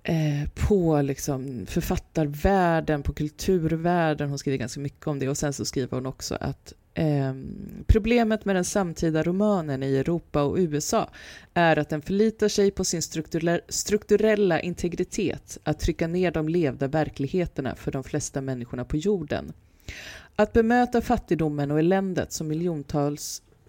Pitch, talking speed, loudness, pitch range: 155 Hz, 140 wpm, -25 LUFS, 140-185 Hz